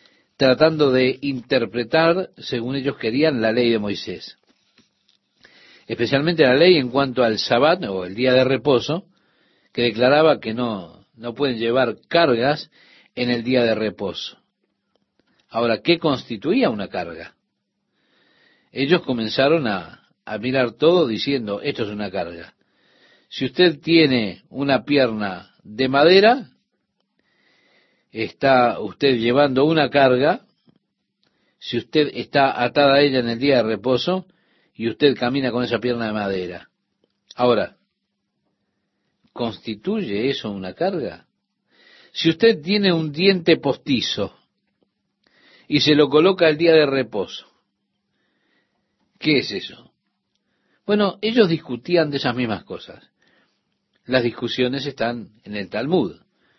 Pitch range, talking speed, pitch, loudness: 115-155 Hz, 125 wpm, 130 Hz, -19 LUFS